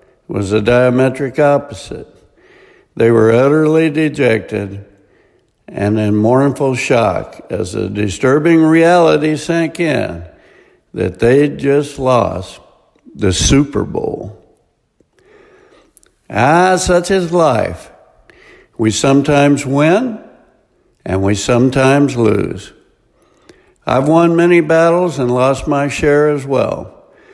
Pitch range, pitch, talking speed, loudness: 115-155 Hz, 135 Hz, 100 wpm, -13 LUFS